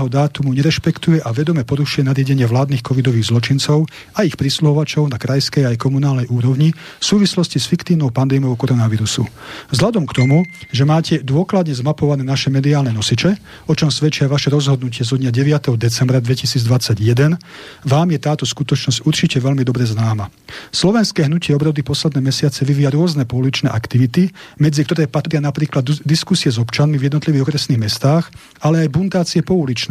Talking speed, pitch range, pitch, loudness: 155 wpm, 130-155 Hz, 145 Hz, -16 LUFS